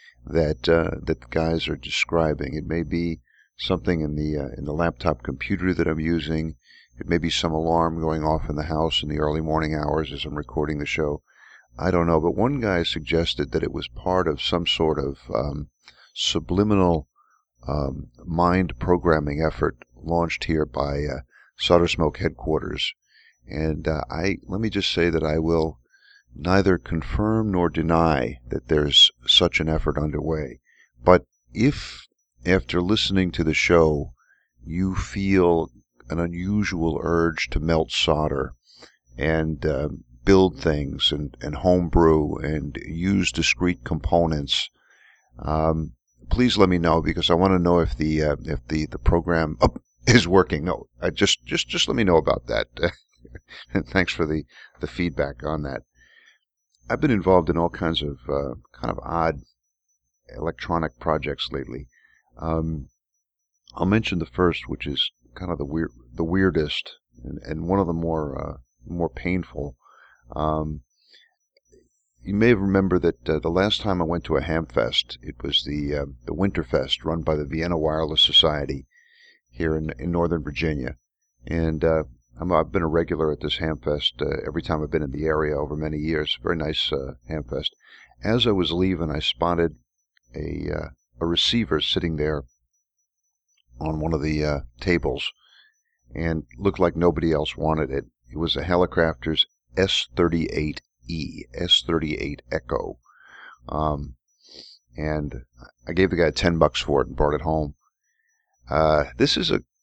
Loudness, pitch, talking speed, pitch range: -23 LUFS, 80 Hz, 160 wpm, 75-85 Hz